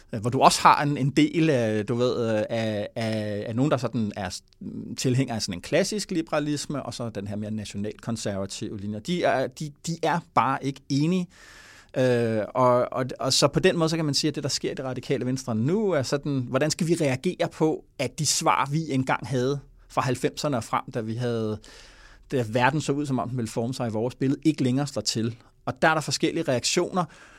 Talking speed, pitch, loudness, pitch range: 225 wpm, 130 Hz, -25 LUFS, 115-155 Hz